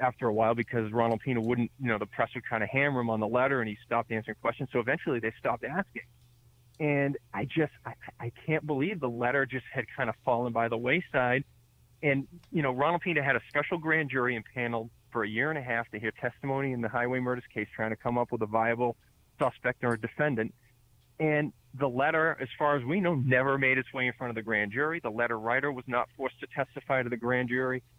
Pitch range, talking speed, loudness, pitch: 115-135 Hz, 240 wpm, -30 LUFS, 125 Hz